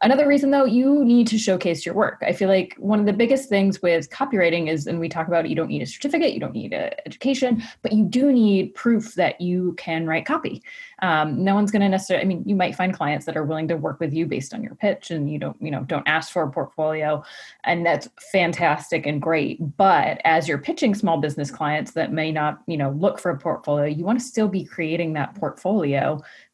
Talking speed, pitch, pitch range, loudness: 240 wpm, 180 Hz, 160-230 Hz, -22 LUFS